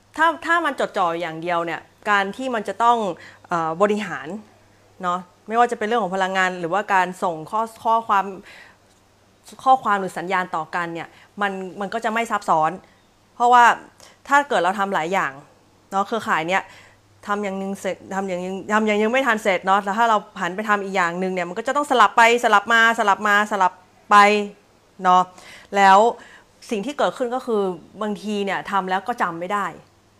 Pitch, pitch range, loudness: 200 Hz, 185-225 Hz, -20 LUFS